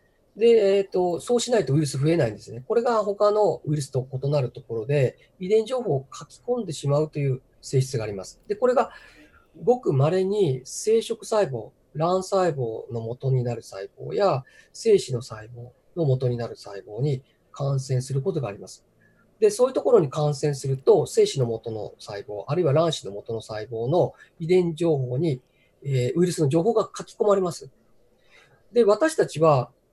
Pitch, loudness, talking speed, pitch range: 150 Hz, -24 LUFS, 345 characters per minute, 125-195 Hz